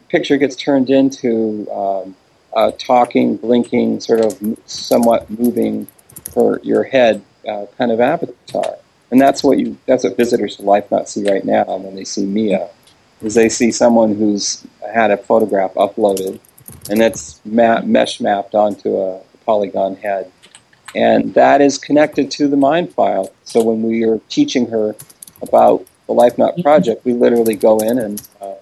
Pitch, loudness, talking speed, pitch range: 115 Hz, -15 LUFS, 165 wpm, 105-120 Hz